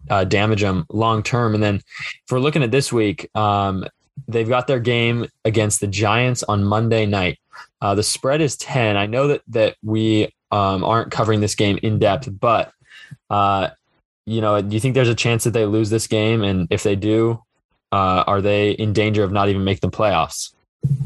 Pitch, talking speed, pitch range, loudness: 110 Hz, 200 wpm, 100-115 Hz, -19 LUFS